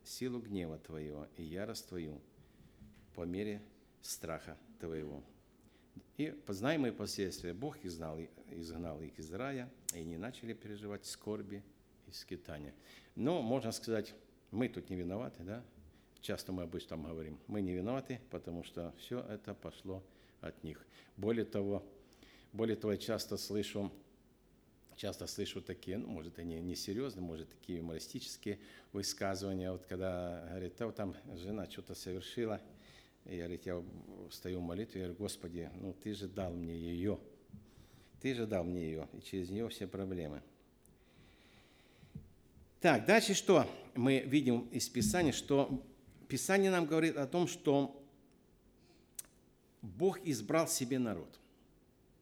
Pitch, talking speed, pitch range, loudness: 100 Hz, 135 wpm, 85-115 Hz, -39 LUFS